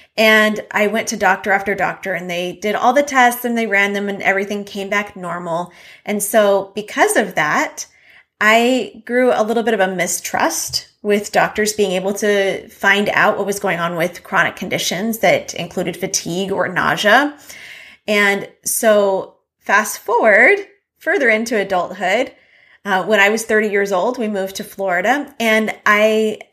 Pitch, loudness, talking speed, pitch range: 205 Hz, -16 LUFS, 165 wpm, 190-220 Hz